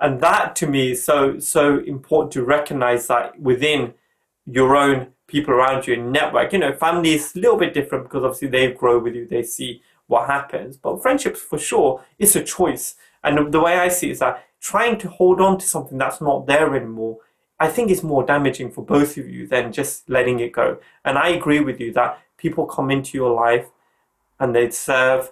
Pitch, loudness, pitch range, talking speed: 140 Hz, -19 LUFS, 125-155 Hz, 215 wpm